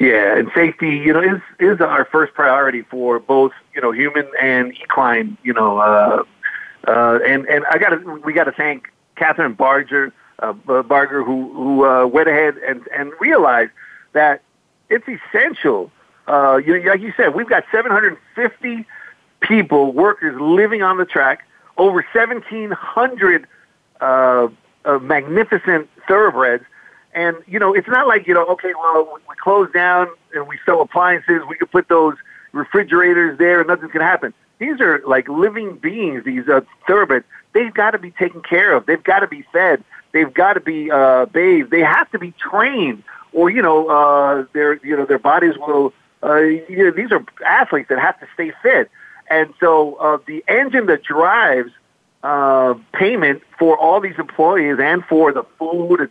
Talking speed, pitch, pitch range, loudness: 175 wpm, 160 Hz, 140-185 Hz, -15 LUFS